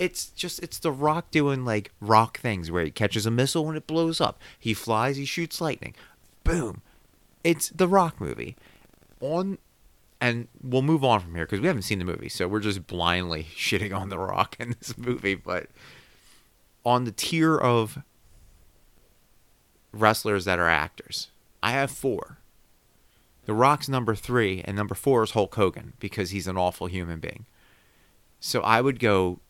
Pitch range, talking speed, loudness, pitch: 95-140 Hz, 170 wpm, -26 LUFS, 115 Hz